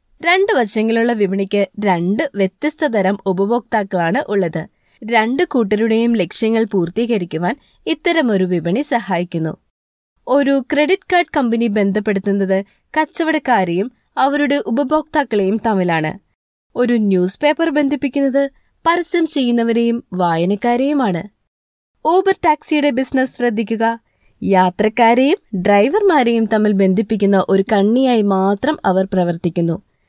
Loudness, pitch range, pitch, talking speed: -16 LUFS, 195-280 Hz, 225 Hz, 85 wpm